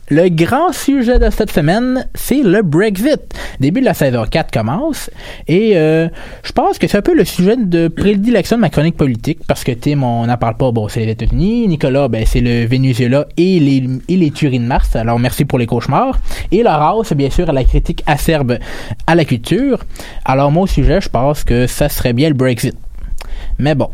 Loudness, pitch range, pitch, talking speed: -14 LUFS, 125-180 Hz, 150 Hz, 210 wpm